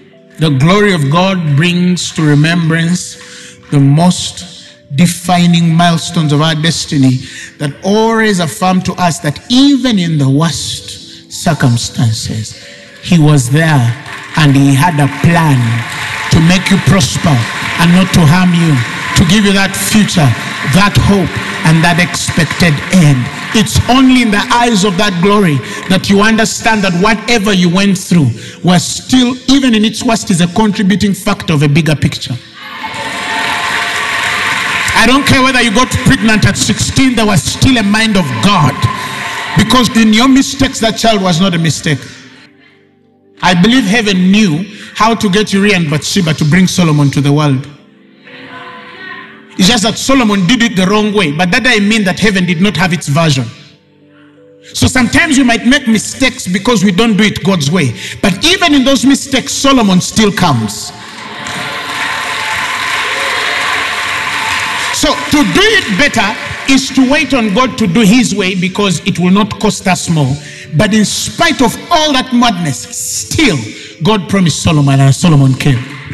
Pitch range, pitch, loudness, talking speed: 150-220 Hz, 180 Hz, -10 LUFS, 160 wpm